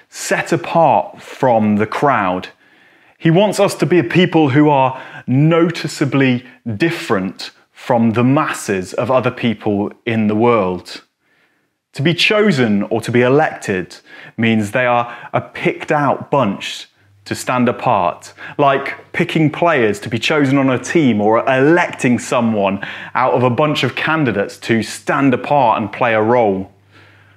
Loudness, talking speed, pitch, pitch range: -15 LUFS, 145 wpm, 125 Hz, 110-150 Hz